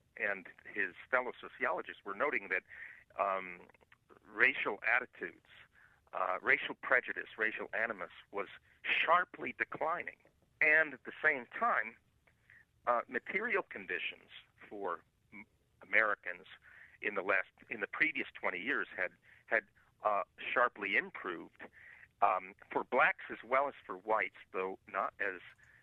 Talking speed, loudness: 125 wpm, -35 LUFS